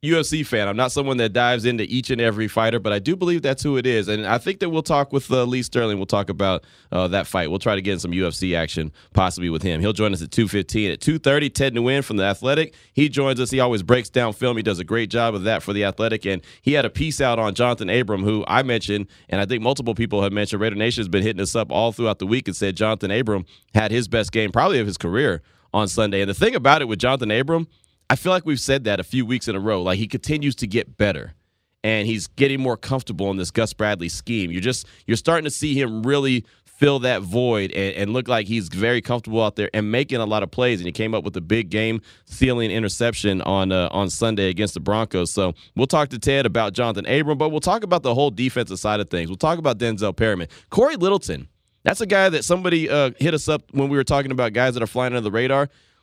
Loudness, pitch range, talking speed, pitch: -21 LUFS, 100-130 Hz, 260 wpm, 115 Hz